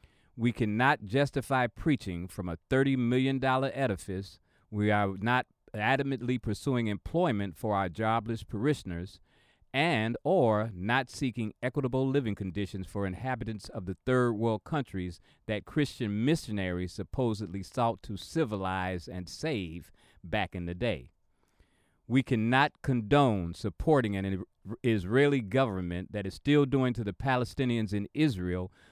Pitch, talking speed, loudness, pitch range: 110 Hz, 130 wpm, -30 LUFS, 95-130 Hz